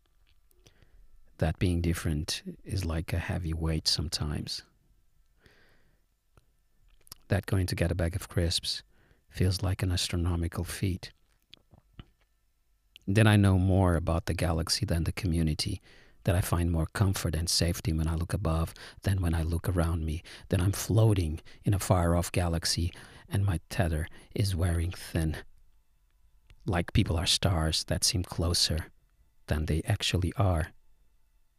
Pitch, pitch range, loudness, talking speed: 90 Hz, 80-100 Hz, -29 LUFS, 140 wpm